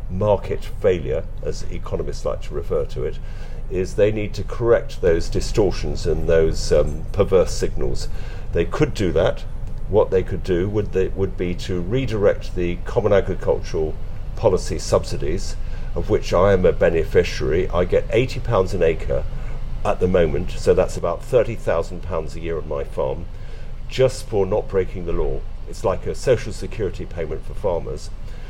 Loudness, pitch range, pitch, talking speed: -22 LUFS, 90-120 Hz, 100 Hz, 175 wpm